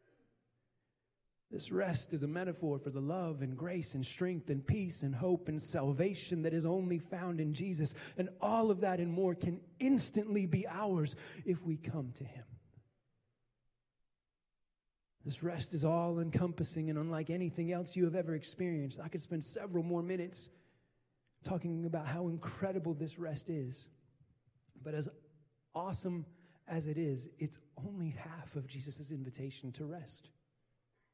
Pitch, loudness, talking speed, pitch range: 160 Hz, -38 LUFS, 150 wpm, 140-175 Hz